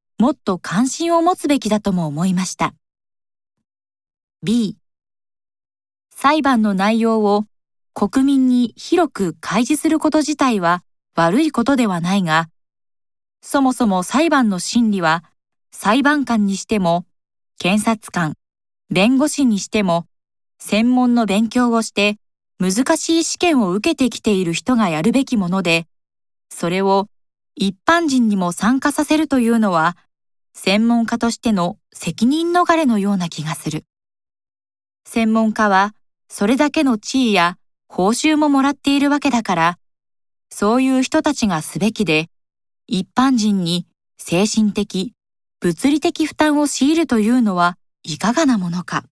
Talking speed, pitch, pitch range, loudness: 255 characters per minute, 220 Hz, 185-270 Hz, -17 LUFS